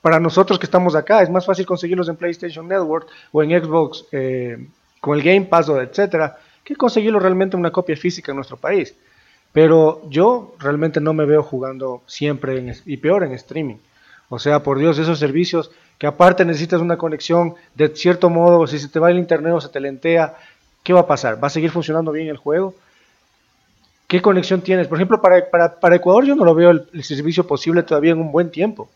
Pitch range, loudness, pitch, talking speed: 150-180 Hz, -16 LUFS, 165 Hz, 210 wpm